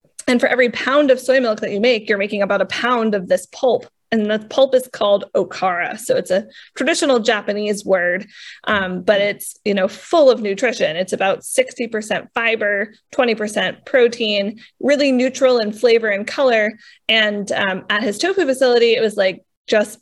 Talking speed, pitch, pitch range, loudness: 185 wpm, 220 Hz, 205-255 Hz, -17 LUFS